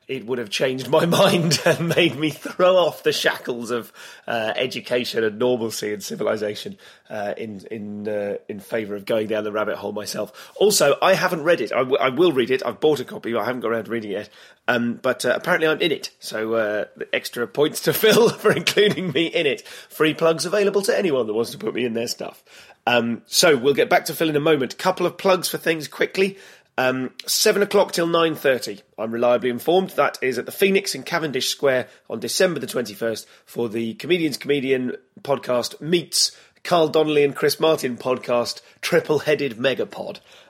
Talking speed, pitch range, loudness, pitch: 205 wpm, 120-180 Hz, -21 LUFS, 150 Hz